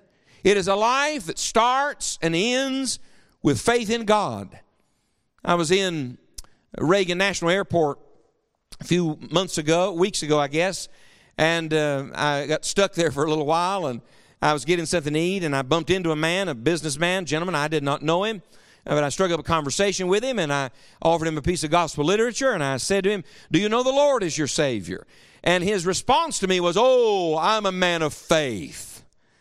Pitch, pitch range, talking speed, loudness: 175 Hz, 155-195 Hz, 205 wpm, -22 LUFS